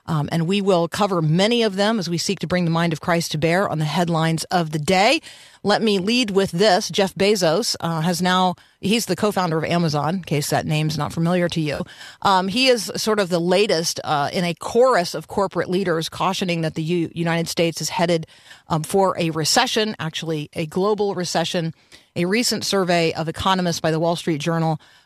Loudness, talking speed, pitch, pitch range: -20 LUFS, 215 wpm, 175 Hz, 165-195 Hz